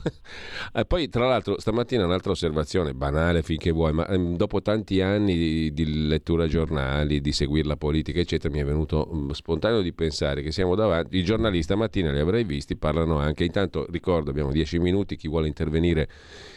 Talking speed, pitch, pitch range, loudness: 180 wpm, 80 Hz, 75-90 Hz, -25 LUFS